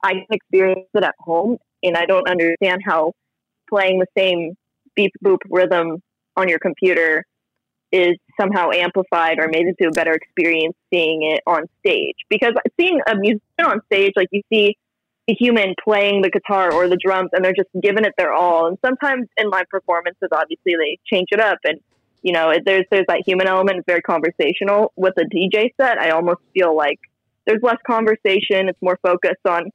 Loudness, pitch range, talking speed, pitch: -17 LUFS, 175-210 Hz, 185 wpm, 190 Hz